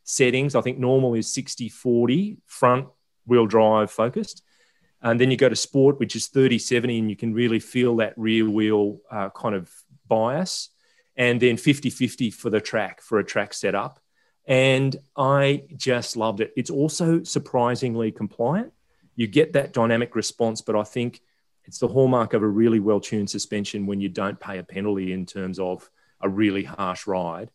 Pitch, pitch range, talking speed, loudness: 120 Hz, 110-130 Hz, 180 wpm, -23 LUFS